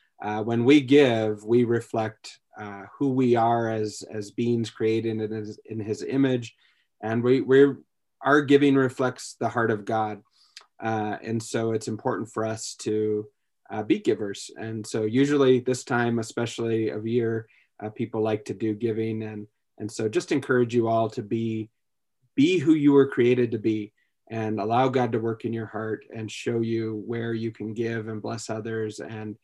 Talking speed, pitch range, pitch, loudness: 180 wpm, 110-120 Hz, 115 Hz, -25 LUFS